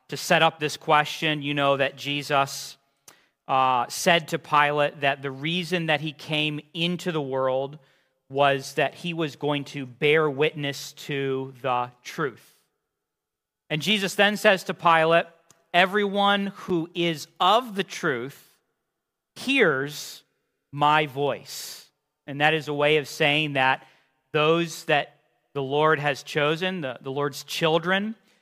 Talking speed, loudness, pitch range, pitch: 140 wpm, -24 LUFS, 140-165 Hz, 150 Hz